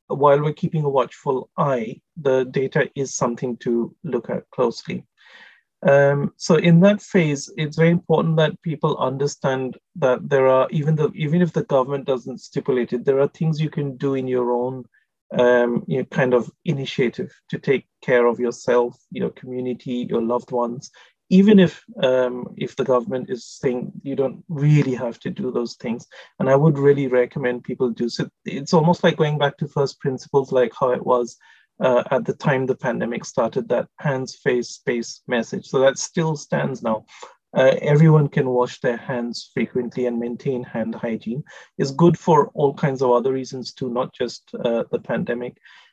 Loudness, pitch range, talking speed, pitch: -21 LUFS, 125-155 Hz, 185 wpm, 135 Hz